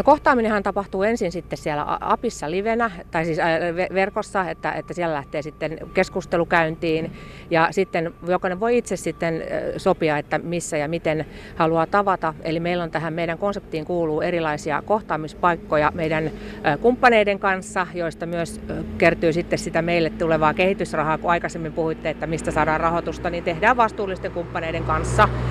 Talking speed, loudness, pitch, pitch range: 145 wpm, -22 LUFS, 170 Hz, 160-190 Hz